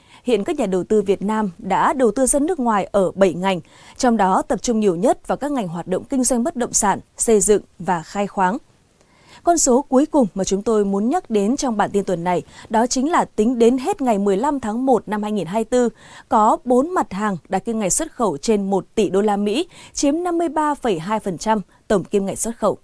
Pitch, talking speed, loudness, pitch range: 220 Hz, 225 wpm, -19 LUFS, 195-255 Hz